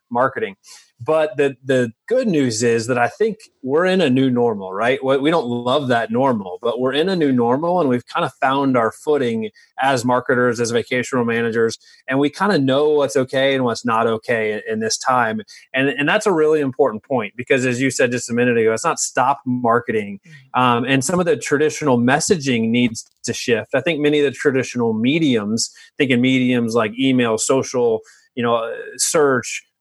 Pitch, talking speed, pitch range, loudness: 130 Hz, 195 wpm, 120-150 Hz, -18 LUFS